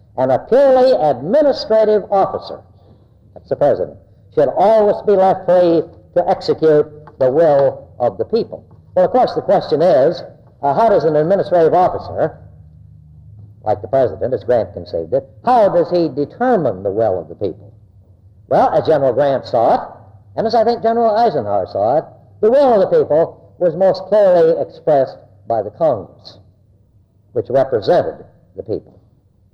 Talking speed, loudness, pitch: 160 wpm, -15 LUFS, 175 Hz